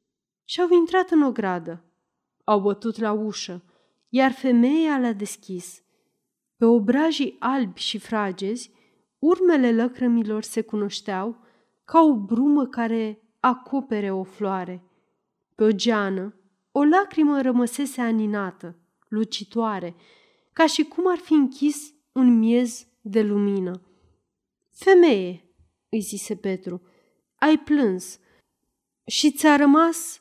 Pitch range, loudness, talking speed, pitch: 200-280 Hz, -22 LUFS, 115 wpm, 230 Hz